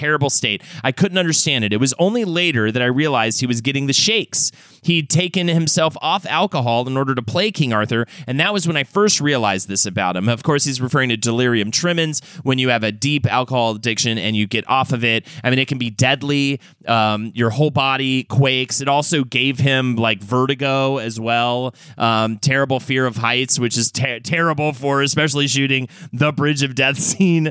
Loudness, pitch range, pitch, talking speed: -17 LUFS, 120-150 Hz, 135 Hz, 210 wpm